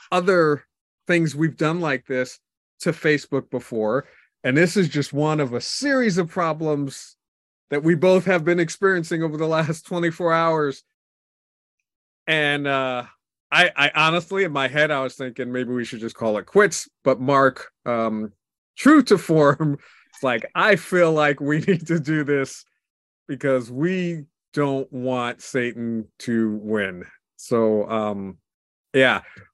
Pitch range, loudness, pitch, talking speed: 125-165 Hz, -21 LUFS, 145 Hz, 150 wpm